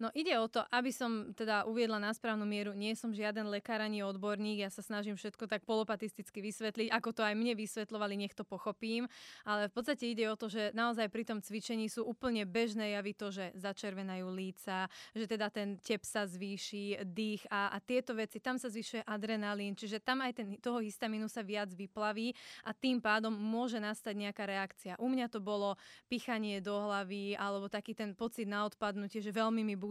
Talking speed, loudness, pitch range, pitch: 195 wpm, -38 LUFS, 205-225 Hz, 215 Hz